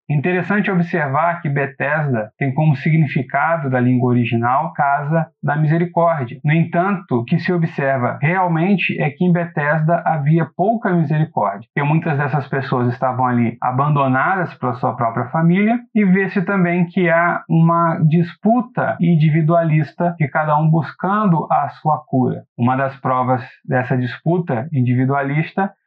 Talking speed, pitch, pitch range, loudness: 135 wpm, 155 Hz, 135-175 Hz, -17 LUFS